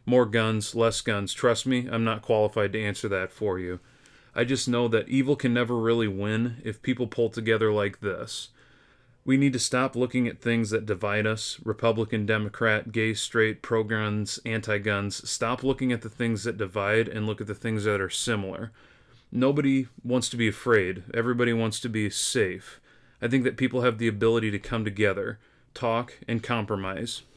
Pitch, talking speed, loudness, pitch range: 115 Hz, 185 wpm, -27 LUFS, 110-125 Hz